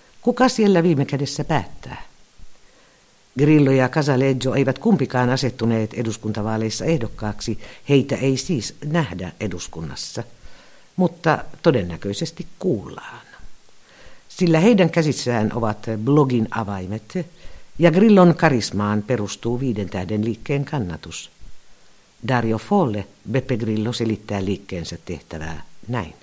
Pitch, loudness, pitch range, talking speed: 125 Hz, -20 LUFS, 105-155 Hz, 95 wpm